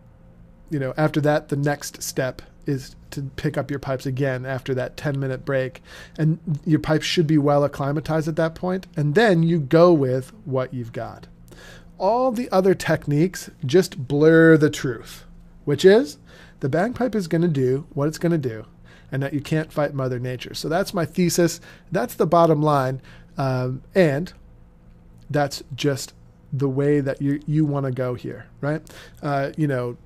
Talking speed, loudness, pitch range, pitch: 180 wpm, -22 LUFS, 130-165 Hz, 145 Hz